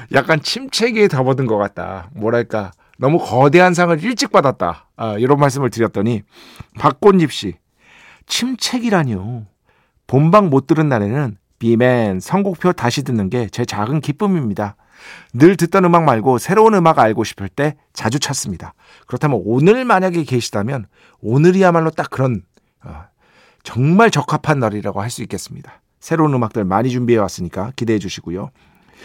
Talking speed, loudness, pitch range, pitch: 320 characters per minute, -16 LUFS, 110-170 Hz, 130 Hz